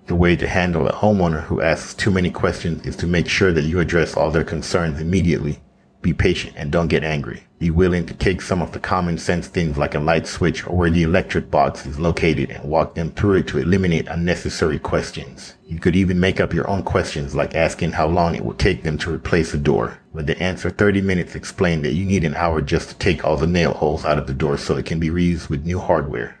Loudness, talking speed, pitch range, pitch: -20 LUFS, 245 wpm, 80-90 Hz, 85 Hz